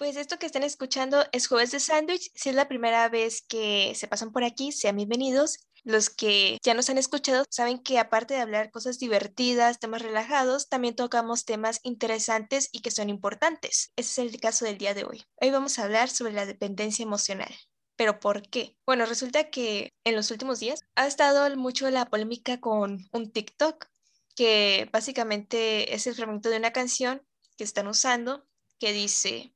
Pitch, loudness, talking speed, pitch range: 235 Hz, -26 LUFS, 185 wpm, 220-265 Hz